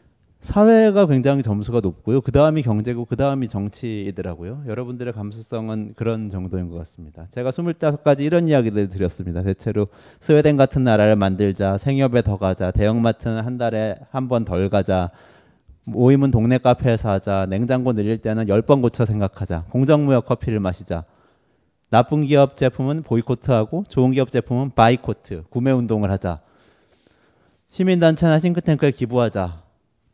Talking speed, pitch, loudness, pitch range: 355 characters per minute, 115 Hz, -19 LUFS, 100-135 Hz